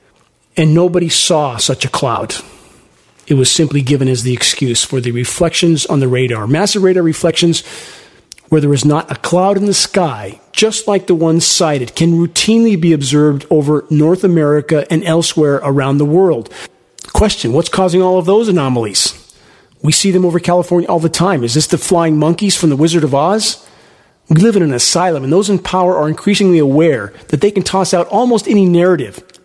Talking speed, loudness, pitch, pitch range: 190 wpm, -12 LUFS, 165 Hz, 145-185 Hz